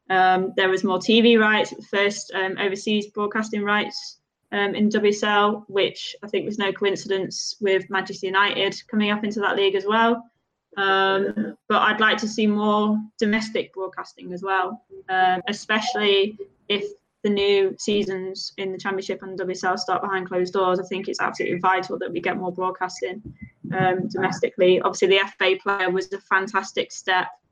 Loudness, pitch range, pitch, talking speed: -22 LUFS, 190-210 Hz, 195 Hz, 170 wpm